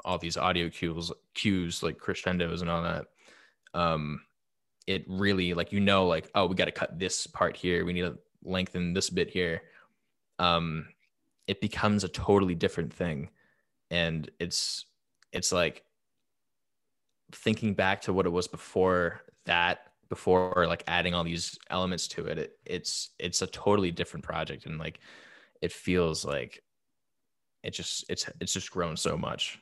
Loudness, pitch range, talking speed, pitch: -30 LUFS, 85-95 Hz, 160 wpm, 90 Hz